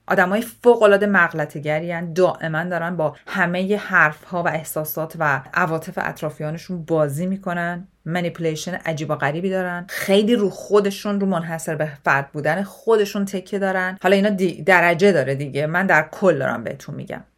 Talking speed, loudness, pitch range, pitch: 150 wpm, -20 LUFS, 155-195 Hz, 175 Hz